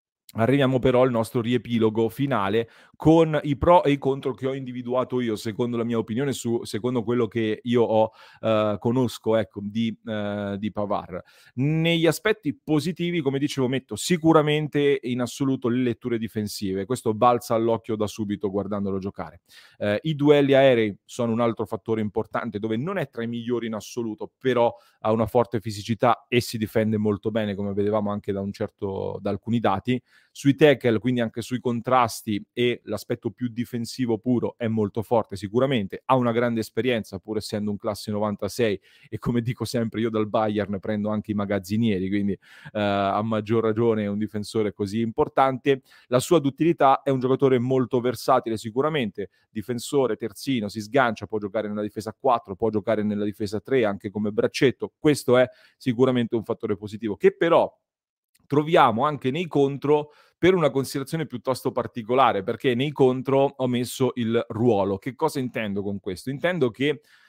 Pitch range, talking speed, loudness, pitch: 110-130 Hz, 170 wpm, -24 LUFS, 115 Hz